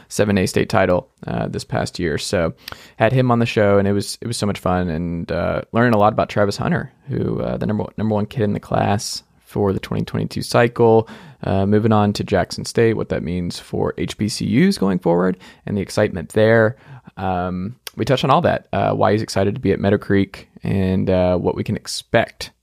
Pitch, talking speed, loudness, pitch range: 100 Hz, 220 wpm, -19 LUFS, 95-110 Hz